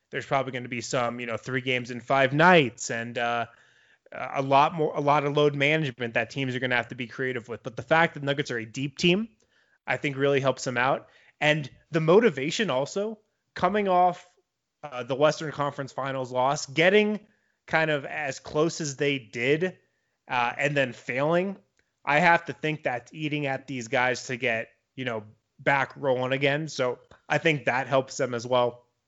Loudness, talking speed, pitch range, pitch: -26 LUFS, 200 wpm, 125-155 Hz, 140 Hz